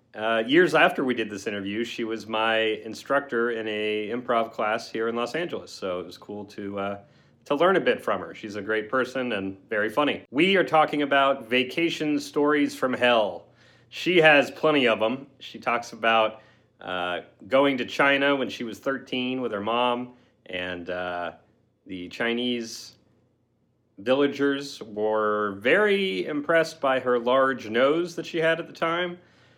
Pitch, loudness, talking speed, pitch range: 120 Hz, -24 LUFS, 170 wpm, 110-140 Hz